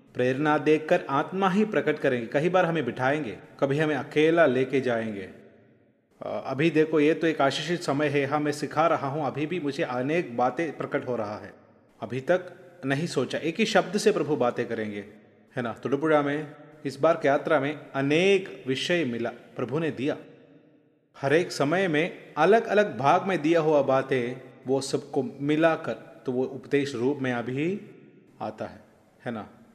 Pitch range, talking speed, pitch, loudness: 130-160 Hz, 175 wpm, 145 Hz, -26 LUFS